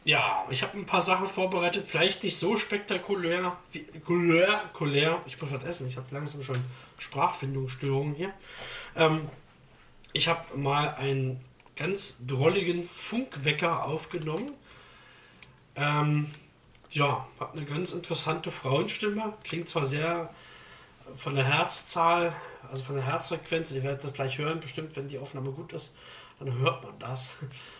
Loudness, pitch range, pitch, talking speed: -29 LUFS, 135-175 Hz, 155 Hz, 140 wpm